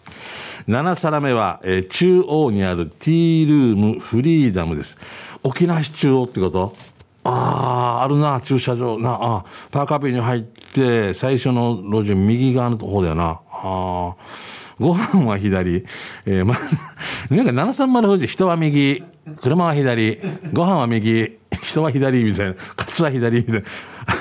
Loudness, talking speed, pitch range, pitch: -19 LUFS, 255 characters per minute, 105-150 Hz, 125 Hz